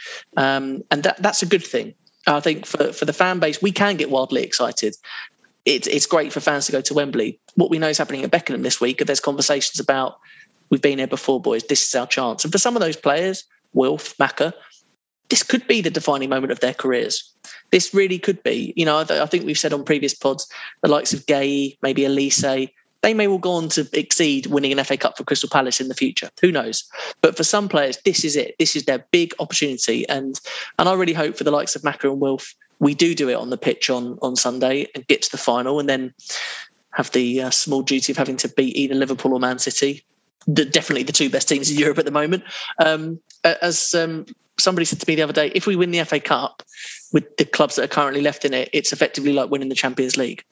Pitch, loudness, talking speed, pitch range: 145 Hz, -20 LUFS, 240 wpm, 135-170 Hz